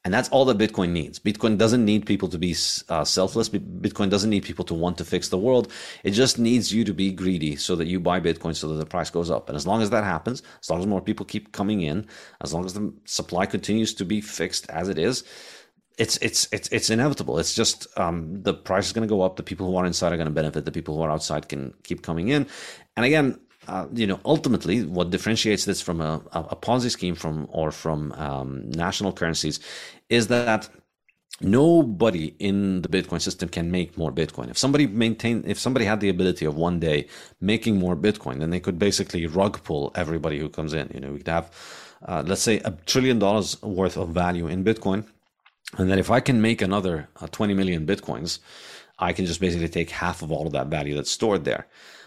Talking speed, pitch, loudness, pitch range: 230 wpm, 95 Hz, -24 LUFS, 85-105 Hz